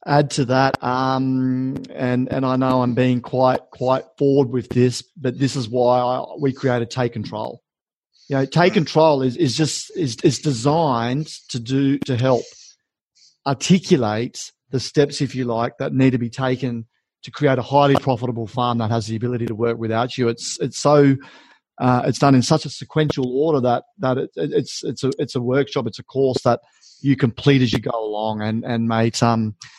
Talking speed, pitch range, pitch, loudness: 195 wpm, 120-140 Hz, 130 Hz, -20 LUFS